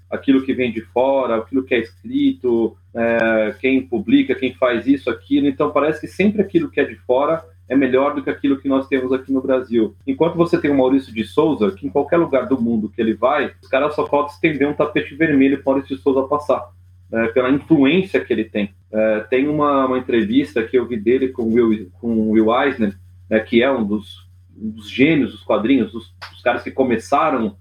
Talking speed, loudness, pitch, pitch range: 220 wpm, -18 LUFS, 130 Hz, 110-145 Hz